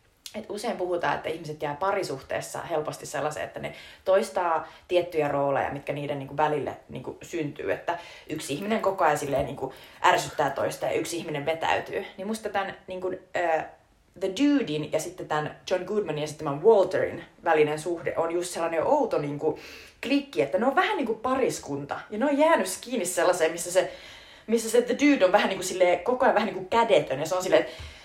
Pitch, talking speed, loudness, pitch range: 180 Hz, 190 wpm, -26 LUFS, 155-215 Hz